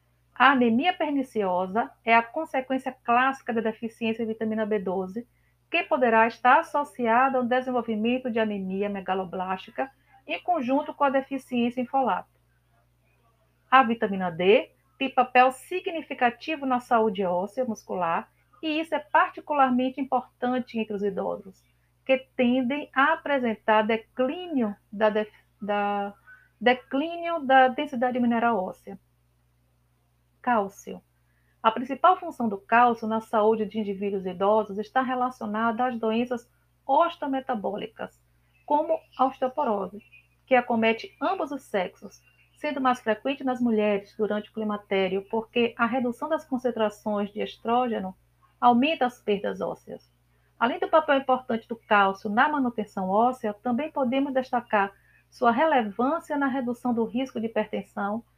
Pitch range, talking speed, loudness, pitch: 210-265 Hz, 125 wpm, -26 LUFS, 235 Hz